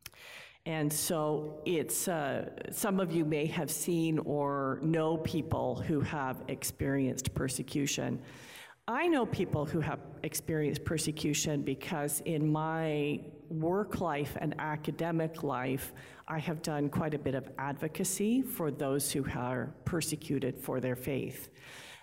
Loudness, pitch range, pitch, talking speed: -34 LUFS, 140-160 Hz, 150 Hz, 130 wpm